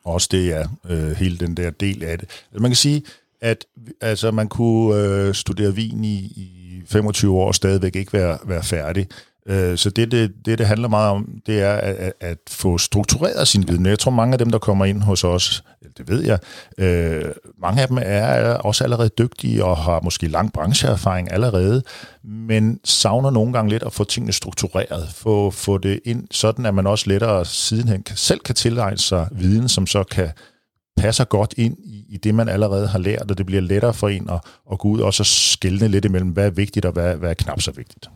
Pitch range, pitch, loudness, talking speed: 95-110 Hz, 100 Hz, -19 LUFS, 215 wpm